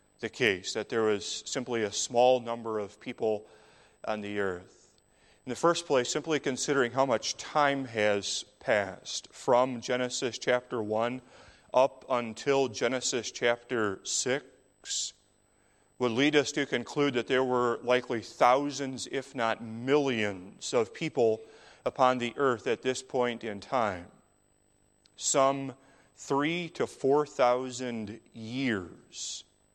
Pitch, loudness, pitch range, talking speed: 125 Hz, -30 LUFS, 115-135 Hz, 125 wpm